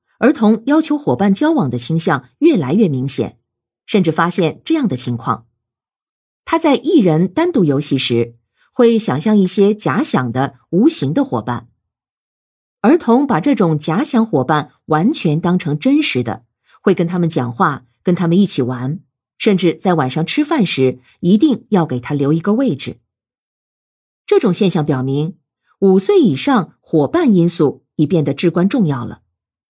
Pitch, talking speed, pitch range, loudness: 170 Hz, 230 characters per minute, 135-220 Hz, -15 LUFS